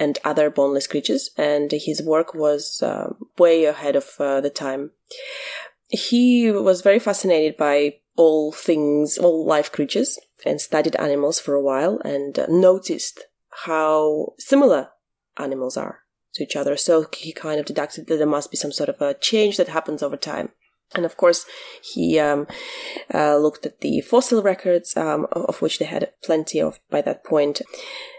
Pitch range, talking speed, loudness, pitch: 145-220 Hz, 170 wpm, -20 LUFS, 155 Hz